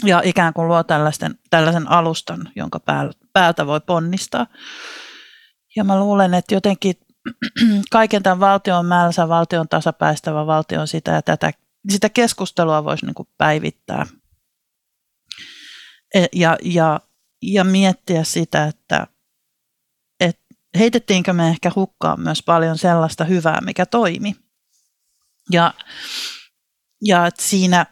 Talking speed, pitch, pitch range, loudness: 110 wpm, 175 Hz, 165-200 Hz, -17 LUFS